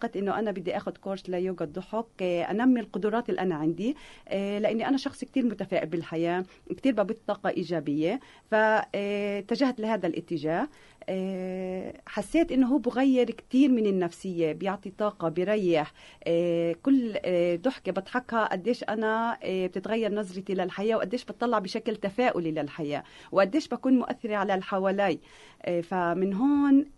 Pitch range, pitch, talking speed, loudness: 180-230 Hz, 200 Hz, 120 wpm, -28 LUFS